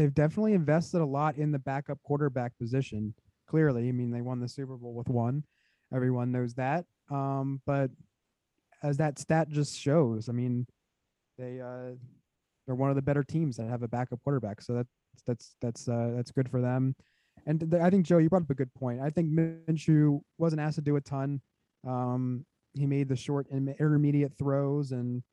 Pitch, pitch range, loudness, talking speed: 135 Hz, 125-150 Hz, -30 LUFS, 195 wpm